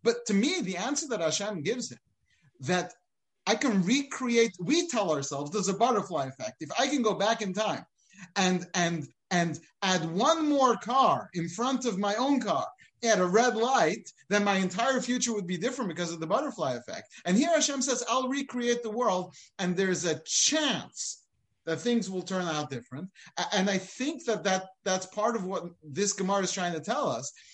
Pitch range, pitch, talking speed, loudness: 180-240 Hz, 200 Hz, 195 wpm, -29 LUFS